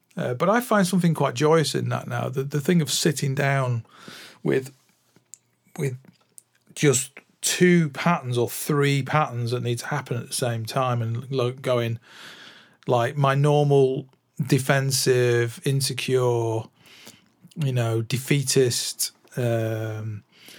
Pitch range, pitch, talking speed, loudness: 120-150 Hz, 135 Hz, 125 wpm, -23 LUFS